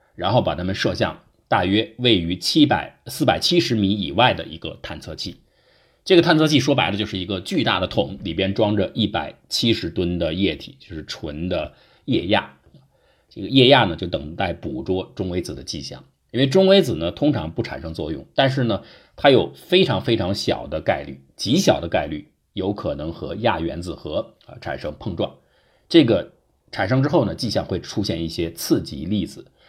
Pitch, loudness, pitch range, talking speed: 105 Hz, -21 LUFS, 90-140 Hz, 280 characters per minute